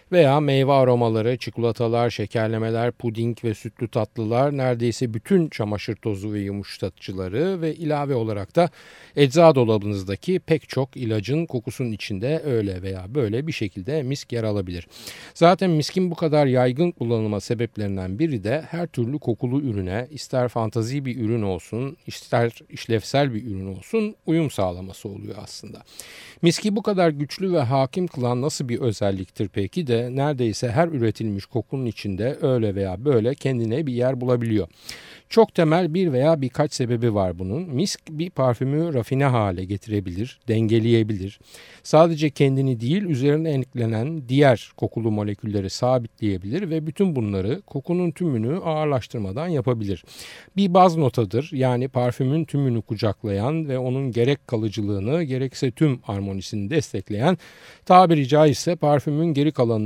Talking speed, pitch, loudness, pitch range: 135 wpm, 125 Hz, -22 LUFS, 110-150 Hz